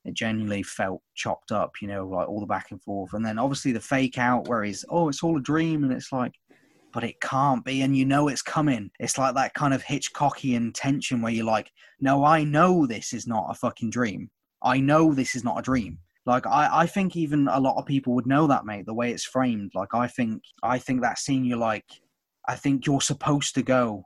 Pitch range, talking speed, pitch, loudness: 115-140 Hz, 240 wpm, 130 Hz, -25 LUFS